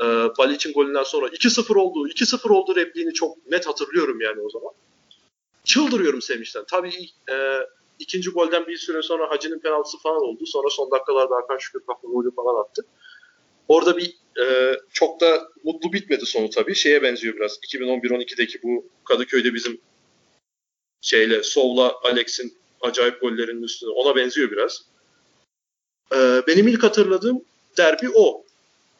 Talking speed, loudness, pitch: 140 wpm, -21 LUFS, 185 Hz